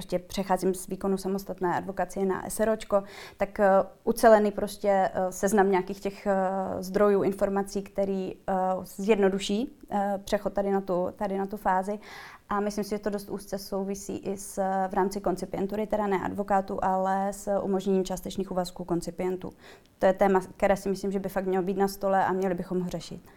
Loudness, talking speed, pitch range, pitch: -28 LUFS, 165 wpm, 190-200 Hz, 195 Hz